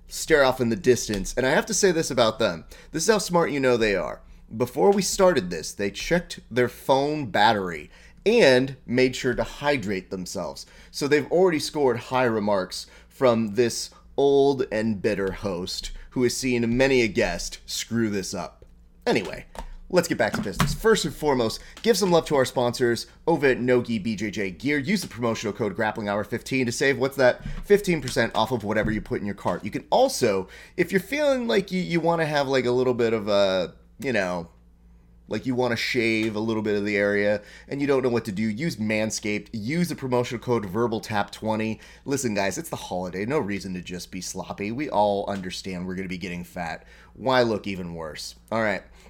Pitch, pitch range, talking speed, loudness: 120 Hz, 100-140 Hz, 205 wpm, -24 LUFS